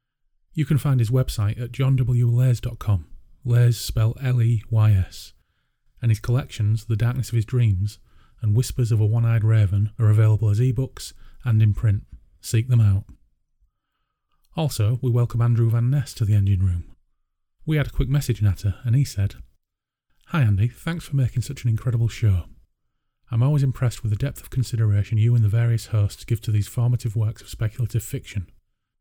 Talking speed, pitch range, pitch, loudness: 175 wpm, 105-125 Hz, 115 Hz, -22 LUFS